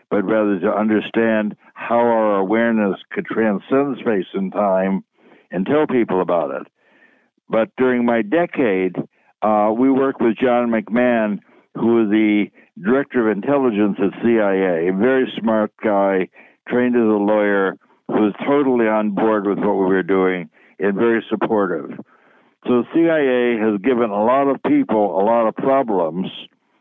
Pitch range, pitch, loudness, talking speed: 105-125 Hz, 110 Hz, -18 LUFS, 155 wpm